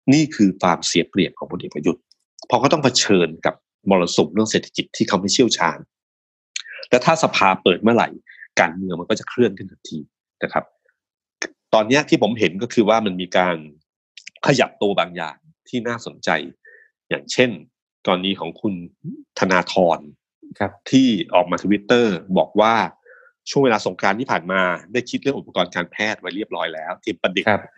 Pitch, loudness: 115 Hz, -19 LUFS